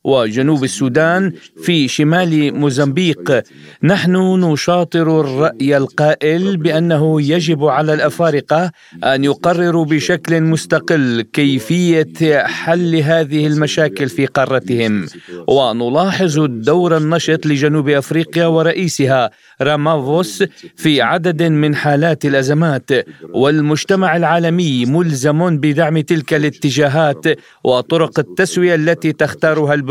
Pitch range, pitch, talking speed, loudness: 145-165 Hz, 155 Hz, 90 wpm, -14 LUFS